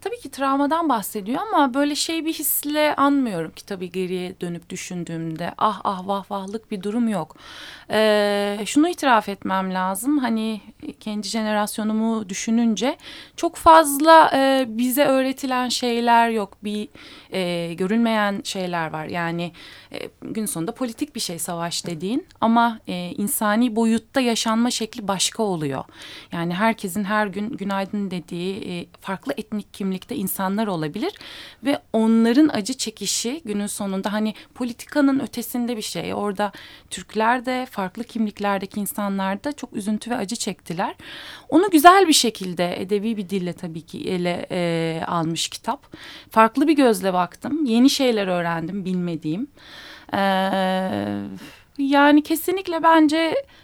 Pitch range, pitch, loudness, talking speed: 190-265 Hz, 215 Hz, -21 LUFS, 135 wpm